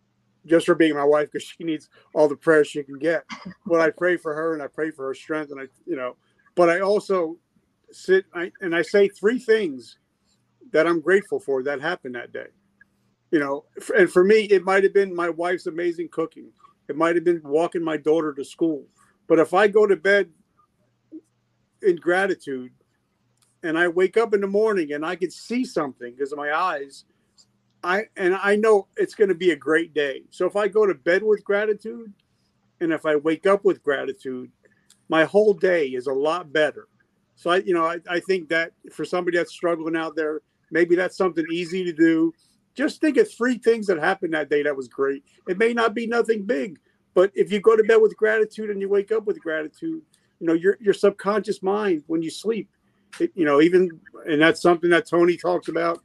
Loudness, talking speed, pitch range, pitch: -22 LUFS, 210 wpm, 160-230 Hz, 185 Hz